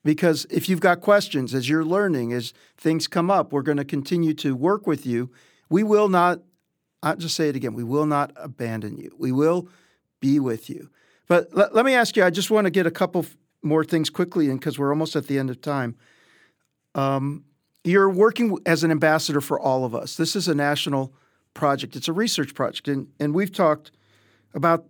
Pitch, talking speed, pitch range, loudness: 155 Hz, 210 wpm, 140-175 Hz, -22 LUFS